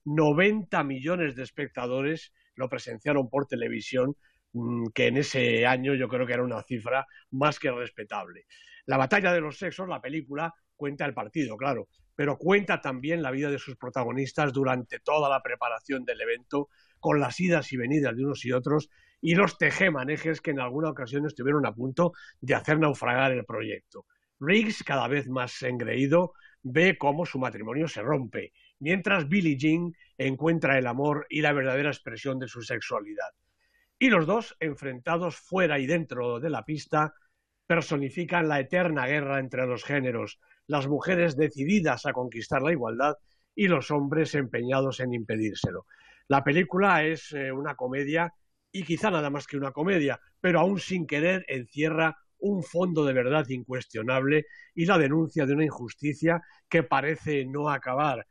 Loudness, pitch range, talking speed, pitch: -27 LUFS, 130-165 Hz, 160 wpm, 145 Hz